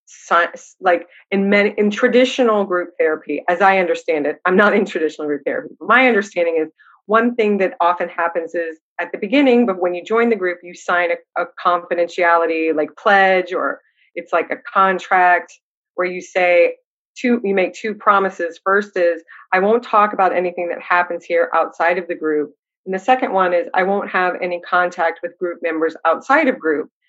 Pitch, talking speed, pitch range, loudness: 180 Hz, 190 wpm, 170-205 Hz, -17 LUFS